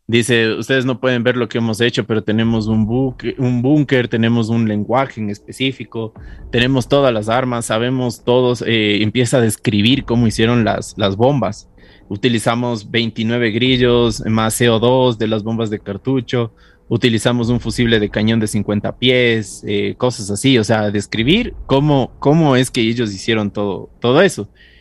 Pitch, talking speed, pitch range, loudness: 115 Hz, 165 wpm, 110-125 Hz, -16 LUFS